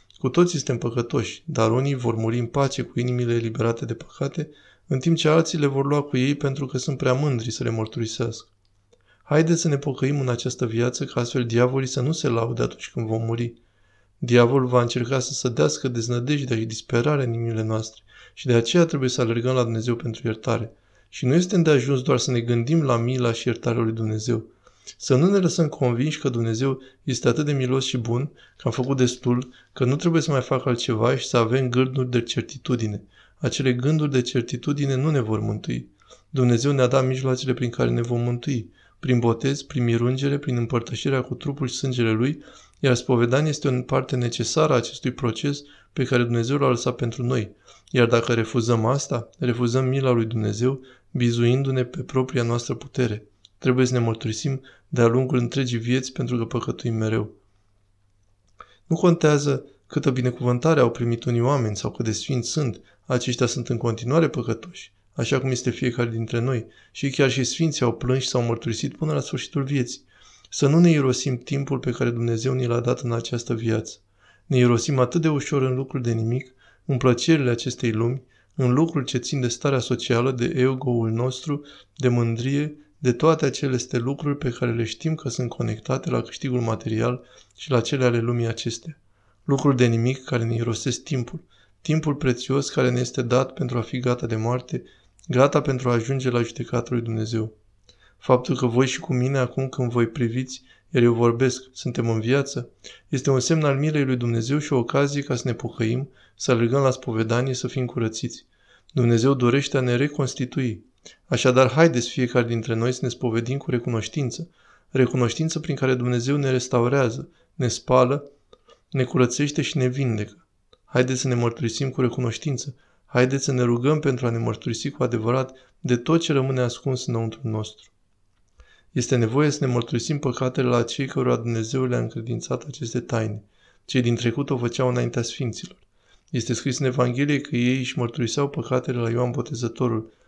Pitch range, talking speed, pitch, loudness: 120-135 Hz, 185 wpm, 125 Hz, -23 LUFS